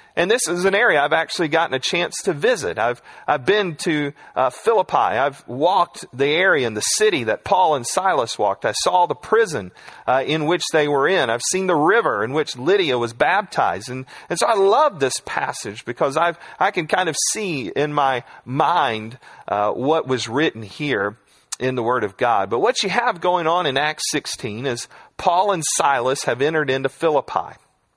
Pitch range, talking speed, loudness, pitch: 130-195 Hz, 200 wpm, -19 LUFS, 160 Hz